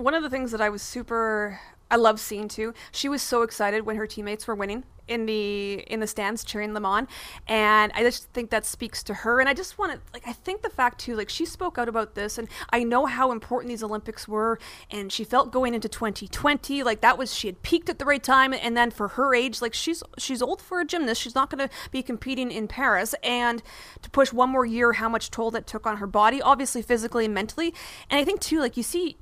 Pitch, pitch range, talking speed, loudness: 235 Hz, 220-265 Hz, 255 wpm, -25 LUFS